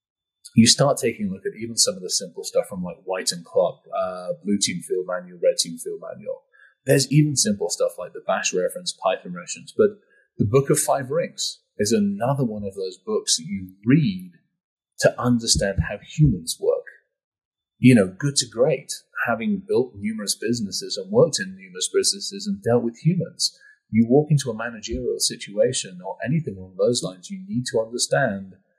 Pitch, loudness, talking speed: 185 Hz, -22 LUFS, 185 wpm